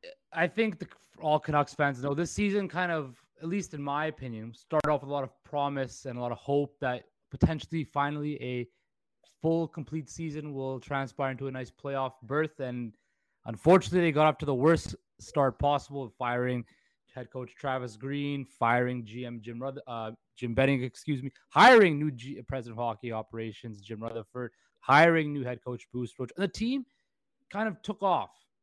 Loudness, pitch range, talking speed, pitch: -29 LUFS, 125-155 Hz, 185 wpm, 140 Hz